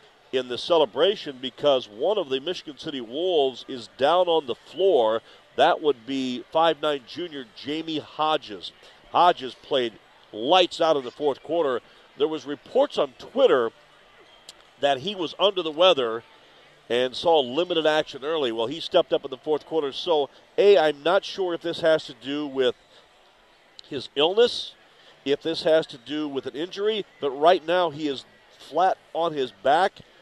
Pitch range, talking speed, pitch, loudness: 135-170 Hz, 165 wpm, 155 Hz, -24 LUFS